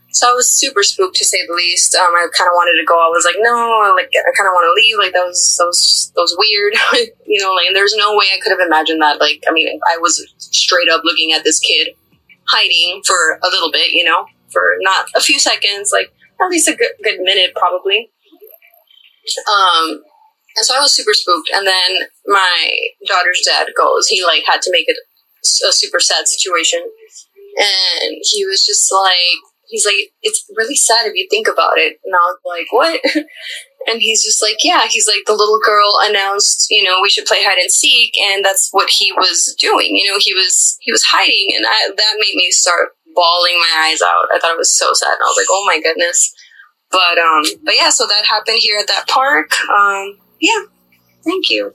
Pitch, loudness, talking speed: 225 Hz, -11 LUFS, 220 wpm